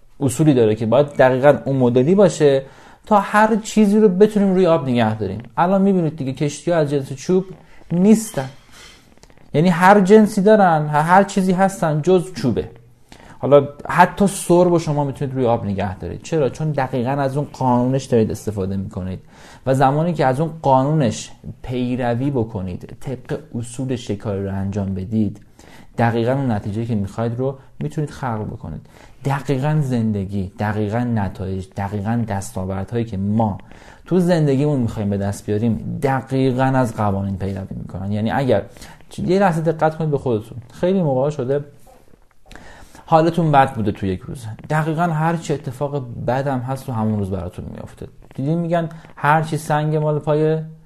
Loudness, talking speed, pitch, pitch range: -18 LUFS, 155 wpm, 135 Hz, 110-155 Hz